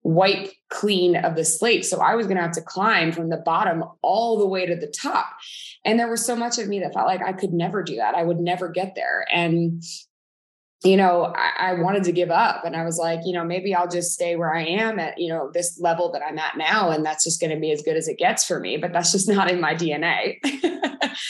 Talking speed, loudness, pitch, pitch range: 260 wpm, -22 LUFS, 180 Hz, 170-200 Hz